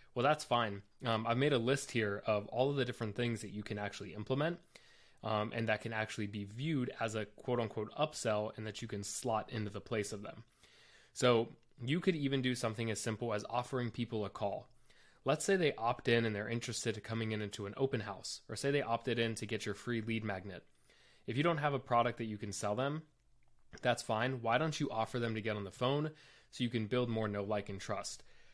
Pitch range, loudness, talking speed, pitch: 105-125 Hz, -37 LUFS, 240 wpm, 115 Hz